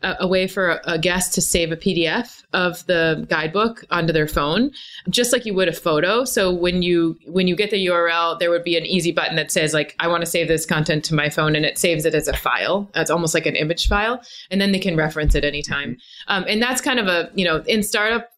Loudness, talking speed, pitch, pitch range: -19 LUFS, 250 wpm, 180 Hz, 165-195 Hz